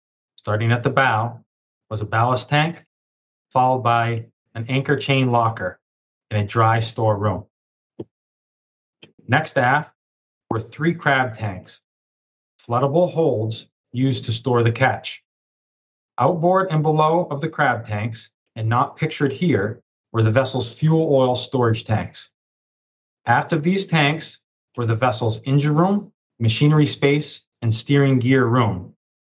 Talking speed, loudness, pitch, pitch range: 135 wpm, -20 LUFS, 125 Hz, 110-145 Hz